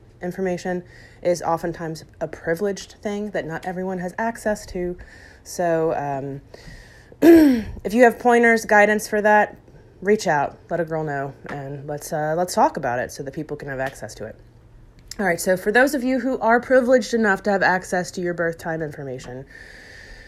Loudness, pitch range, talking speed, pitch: -21 LUFS, 145-215 Hz, 180 wpm, 180 Hz